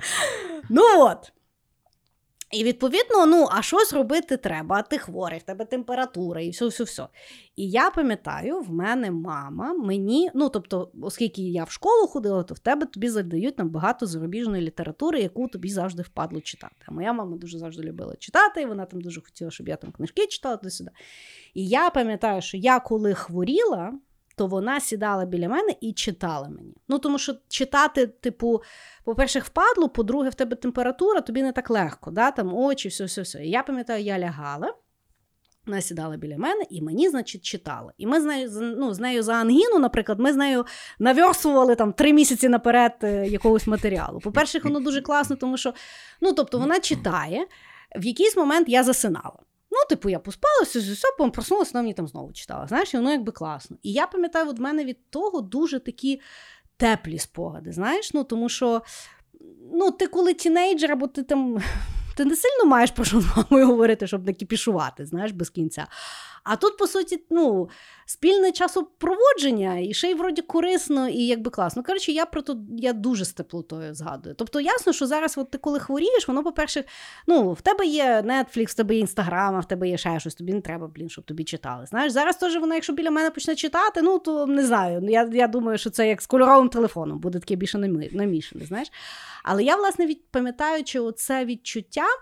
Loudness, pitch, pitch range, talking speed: -23 LUFS, 245 Hz, 200-300 Hz, 190 wpm